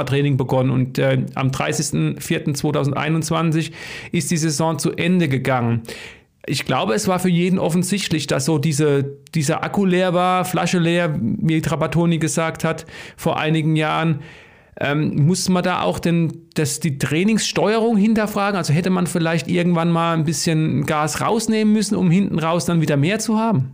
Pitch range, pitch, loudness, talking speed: 155-180 Hz, 165 Hz, -19 LUFS, 160 wpm